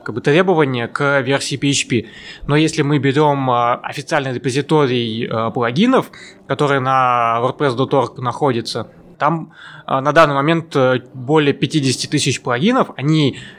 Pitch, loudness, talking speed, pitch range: 140 Hz, -16 LUFS, 105 wpm, 125-150 Hz